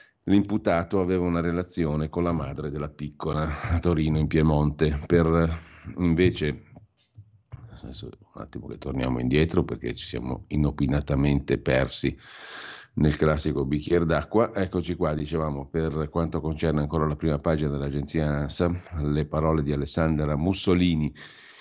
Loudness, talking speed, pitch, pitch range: -25 LUFS, 130 wpm, 80 Hz, 75-90 Hz